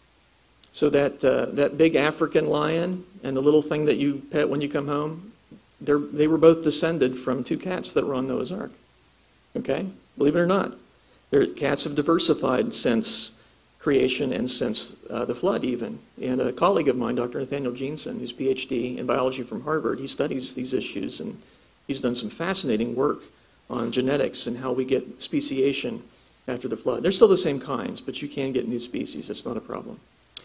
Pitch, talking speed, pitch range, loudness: 145 Hz, 190 wpm, 135-160 Hz, -25 LUFS